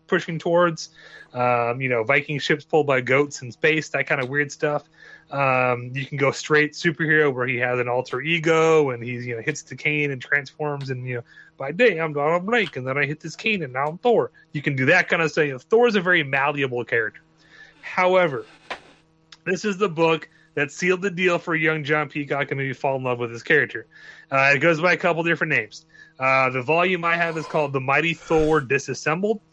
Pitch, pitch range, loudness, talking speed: 150 Hz, 135-170 Hz, -21 LUFS, 225 wpm